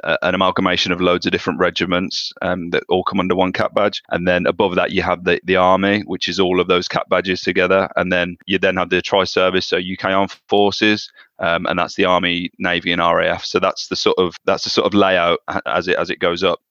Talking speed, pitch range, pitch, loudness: 240 wpm, 90-95 Hz, 90 Hz, -17 LUFS